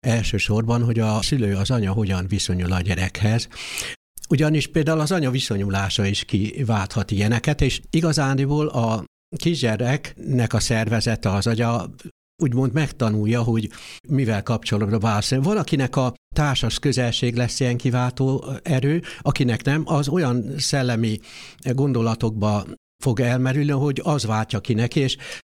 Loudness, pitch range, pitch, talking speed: -22 LUFS, 110-140 Hz, 120 Hz, 125 wpm